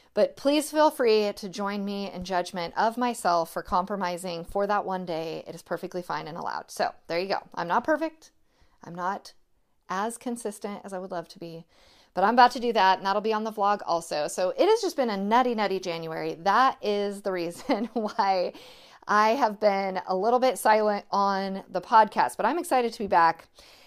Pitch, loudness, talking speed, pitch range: 200 Hz, -26 LUFS, 210 wpm, 180-230 Hz